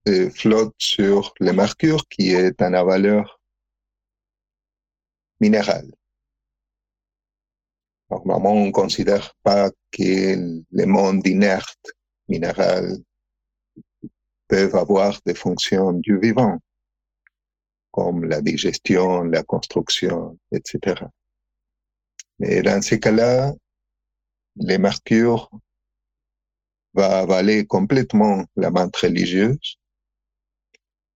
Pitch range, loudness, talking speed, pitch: 65-105 Hz, -19 LUFS, 85 wpm, 95 Hz